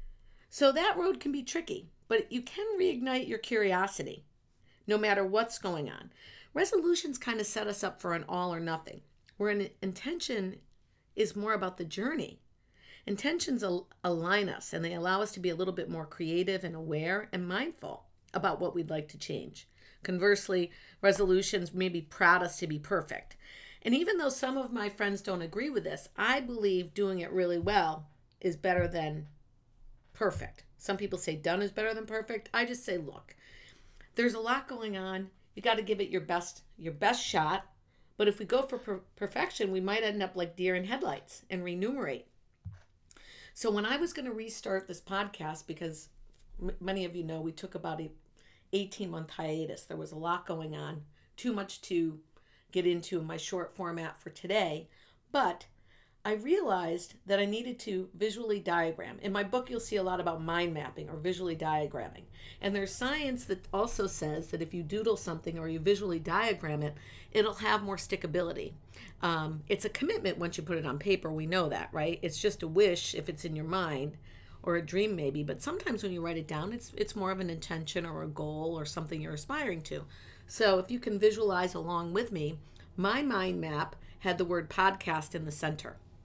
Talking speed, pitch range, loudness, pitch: 195 wpm, 165-210 Hz, -33 LUFS, 185 Hz